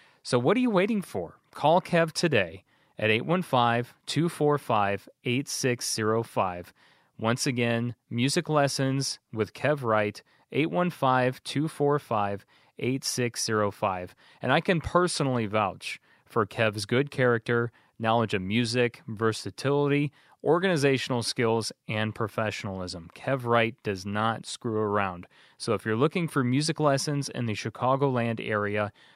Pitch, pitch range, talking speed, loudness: 120 Hz, 110-145 Hz, 115 wpm, -27 LUFS